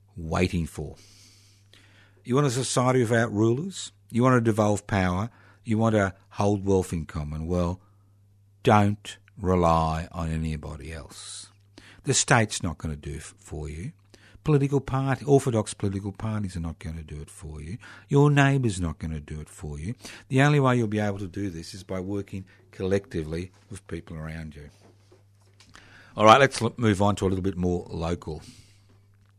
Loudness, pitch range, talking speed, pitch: -25 LUFS, 90-110 Hz, 175 wpm, 100 Hz